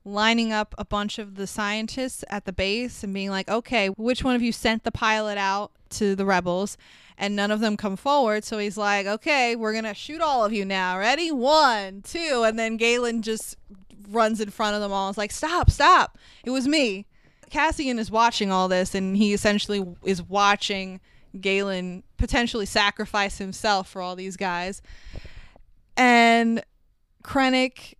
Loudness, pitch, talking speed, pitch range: -23 LUFS, 210 Hz, 175 wpm, 195-230 Hz